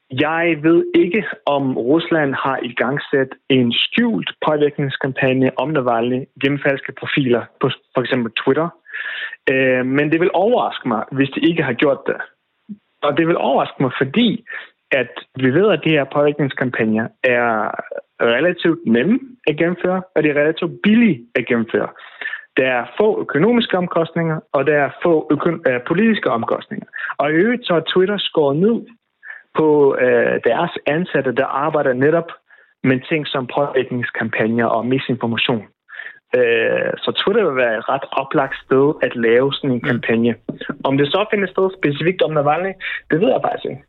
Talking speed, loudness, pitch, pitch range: 165 wpm, -17 LUFS, 150 Hz, 130-190 Hz